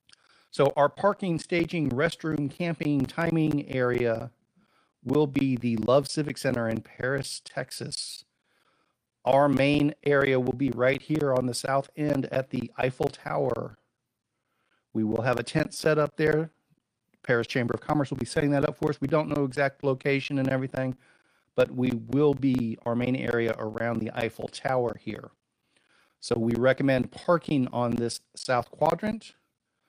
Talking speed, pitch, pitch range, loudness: 155 wpm, 135 Hz, 120-150 Hz, -27 LUFS